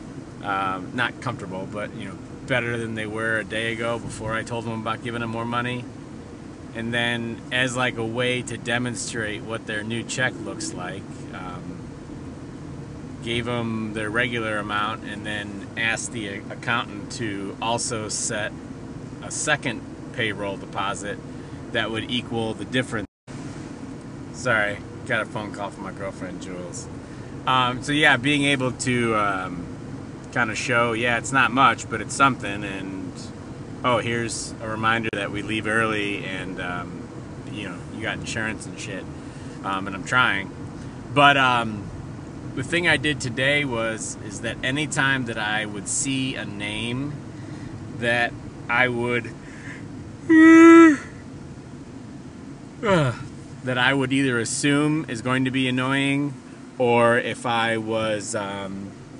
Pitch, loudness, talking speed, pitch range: 120 Hz, -23 LUFS, 145 wpm, 110-135 Hz